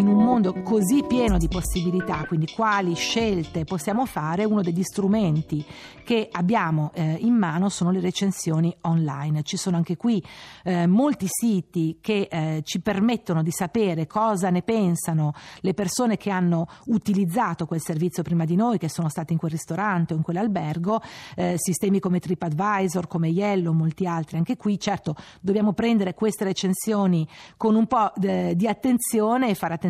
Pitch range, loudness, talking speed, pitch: 170-210 Hz, -24 LUFS, 165 wpm, 185 Hz